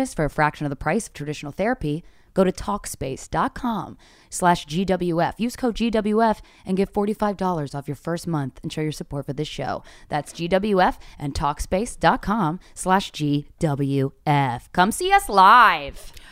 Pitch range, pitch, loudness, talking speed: 145-195 Hz, 170 Hz, -22 LUFS, 150 wpm